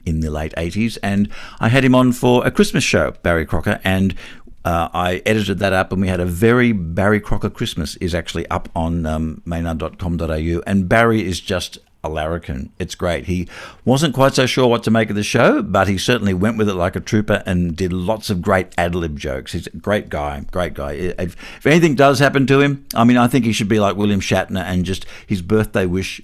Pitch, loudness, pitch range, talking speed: 95 Hz, -18 LUFS, 85-115 Hz, 220 wpm